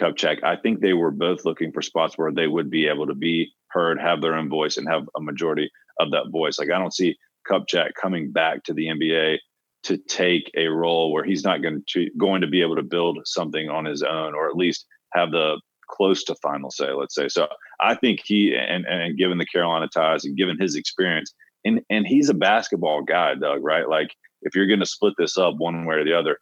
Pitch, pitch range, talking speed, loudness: 85 Hz, 80-90 Hz, 235 wpm, -22 LUFS